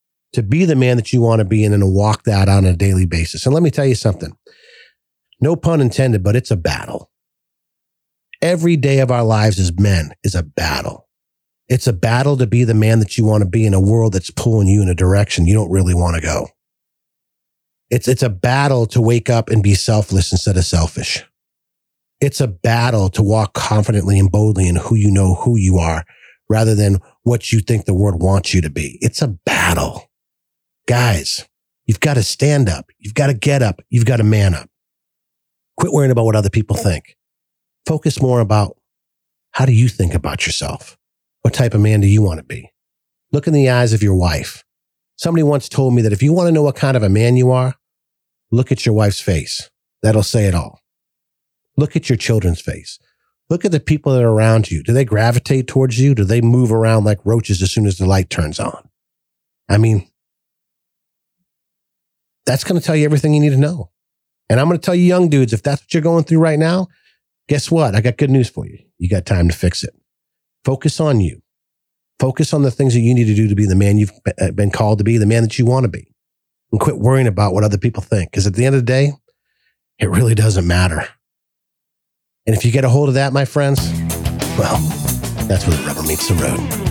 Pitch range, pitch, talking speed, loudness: 100-135 Hz, 115 Hz, 220 wpm, -15 LUFS